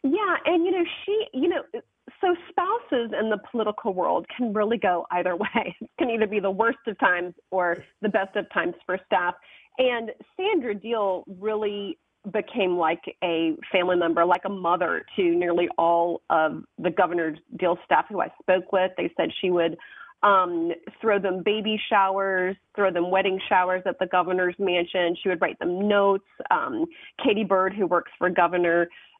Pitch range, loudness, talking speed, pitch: 180-225 Hz, -24 LUFS, 175 wpm, 195 Hz